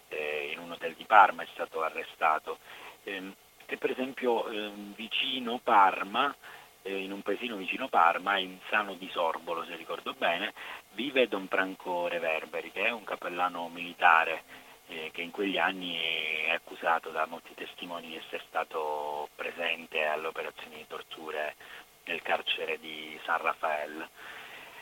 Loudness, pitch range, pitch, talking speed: -30 LUFS, 80-100 Hz, 85 Hz, 145 wpm